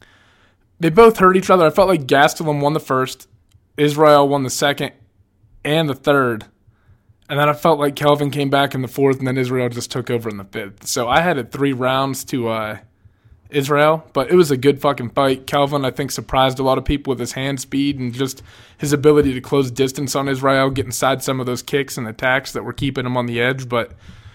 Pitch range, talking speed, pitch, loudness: 120-145 Hz, 225 wpm, 135 Hz, -17 LUFS